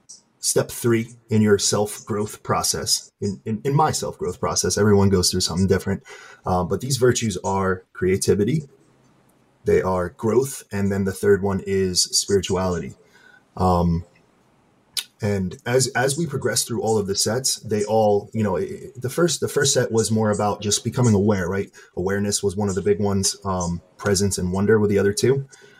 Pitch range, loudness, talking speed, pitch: 95-115 Hz, -21 LUFS, 180 wpm, 100 Hz